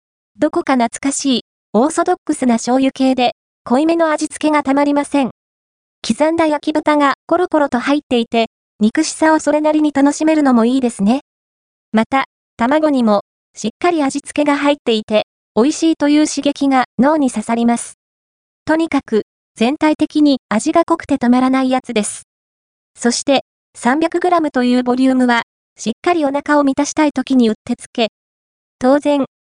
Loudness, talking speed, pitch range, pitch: -15 LUFS, 330 characters per minute, 240-305 Hz, 275 Hz